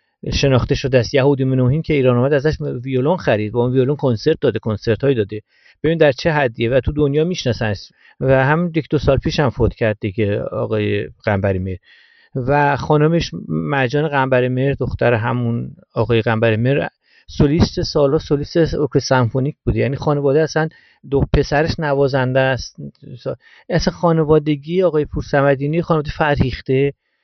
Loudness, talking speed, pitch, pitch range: -17 LUFS, 150 wpm, 135 Hz, 120-150 Hz